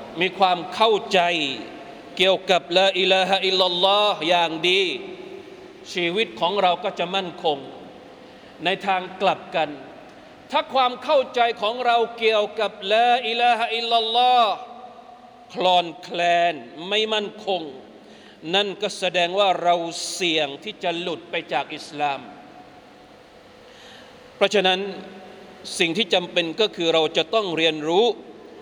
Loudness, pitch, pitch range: -21 LUFS, 195 Hz, 180-235 Hz